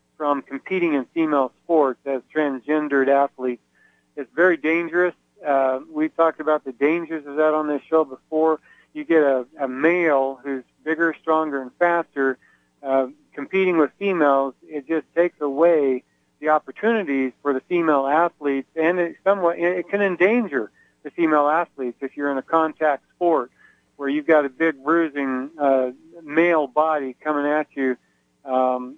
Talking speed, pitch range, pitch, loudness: 155 wpm, 135-165 Hz, 150 Hz, -21 LUFS